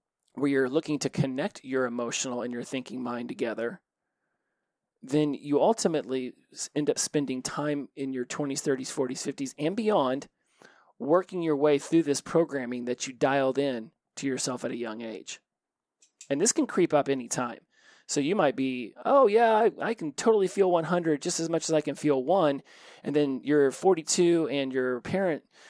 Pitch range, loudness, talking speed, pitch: 130-165 Hz, -27 LUFS, 180 wpm, 145 Hz